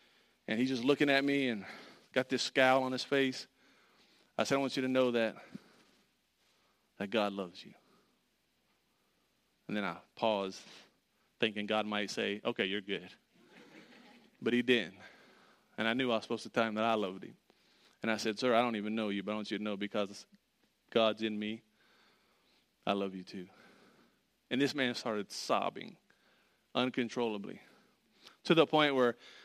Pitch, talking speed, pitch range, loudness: 115 Hz, 175 wpm, 105-130 Hz, -34 LUFS